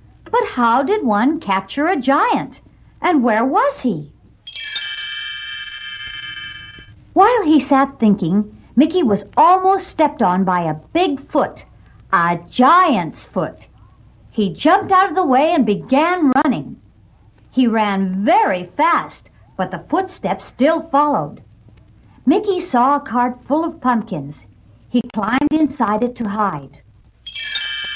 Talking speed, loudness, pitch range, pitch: 125 wpm, -17 LUFS, 195-310 Hz, 245 Hz